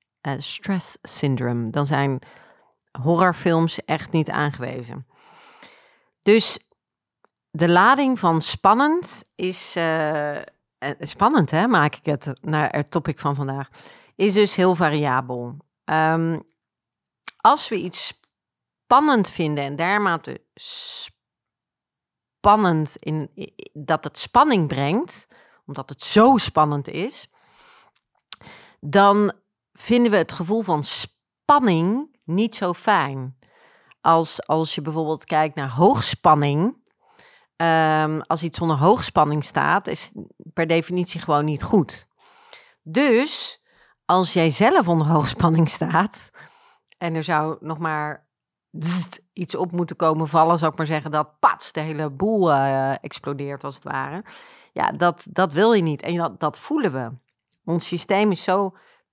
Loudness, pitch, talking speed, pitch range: -21 LUFS, 165 Hz, 130 wpm, 150-205 Hz